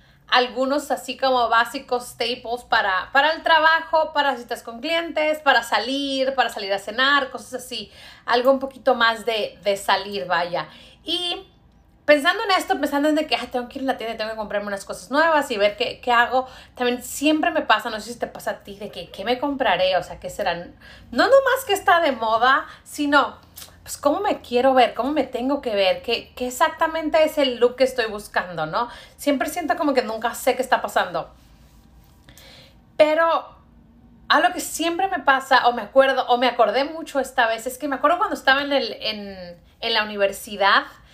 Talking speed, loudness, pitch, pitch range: 200 wpm, -21 LUFS, 250 Hz, 225-290 Hz